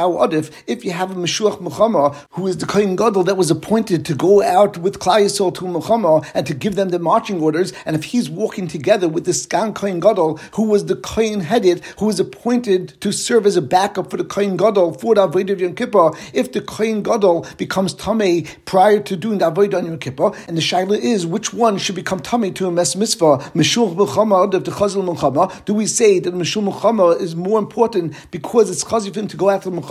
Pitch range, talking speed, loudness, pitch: 175-210 Hz, 215 wpm, -17 LUFS, 190 Hz